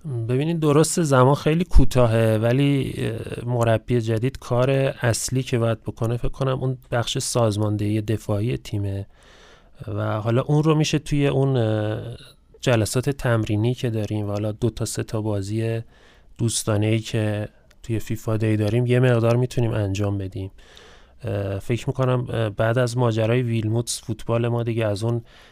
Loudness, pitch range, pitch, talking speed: -22 LUFS, 110-125 Hz, 115 Hz, 140 wpm